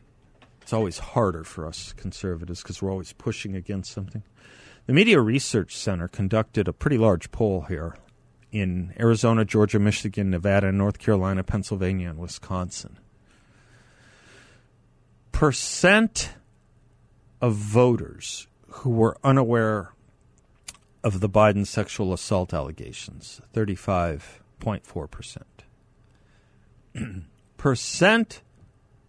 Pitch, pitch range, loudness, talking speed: 105 Hz, 95-115 Hz, -24 LUFS, 95 wpm